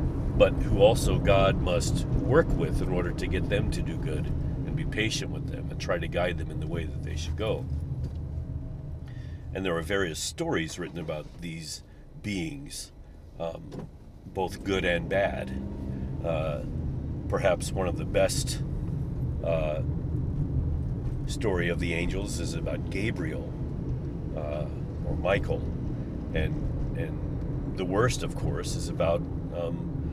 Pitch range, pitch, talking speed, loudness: 70-85 Hz, 80 Hz, 145 wpm, -30 LUFS